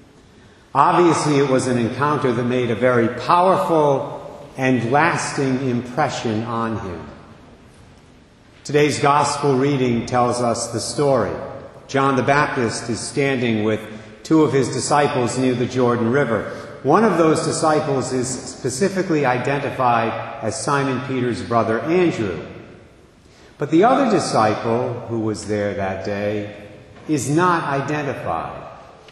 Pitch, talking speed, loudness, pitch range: 130 Hz, 125 wpm, -19 LUFS, 115-145 Hz